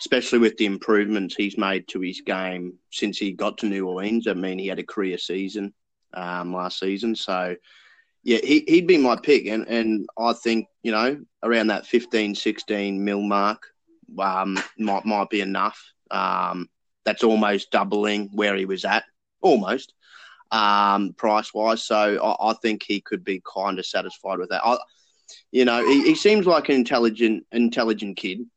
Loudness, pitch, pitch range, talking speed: -22 LUFS, 105 Hz, 95-115 Hz, 175 wpm